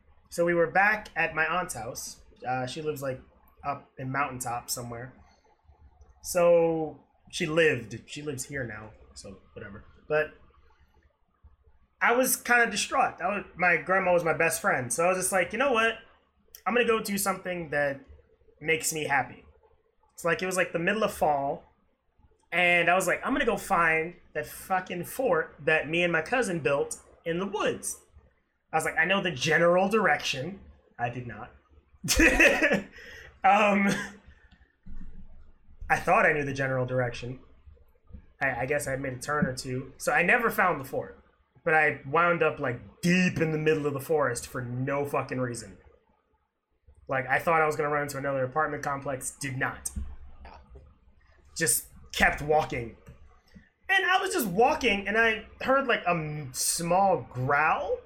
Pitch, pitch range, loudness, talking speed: 155 Hz, 125-185 Hz, -26 LUFS, 170 wpm